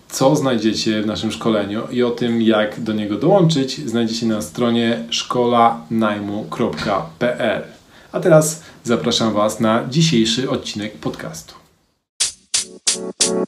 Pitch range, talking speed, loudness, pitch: 105-125 Hz, 105 wpm, -18 LUFS, 115 Hz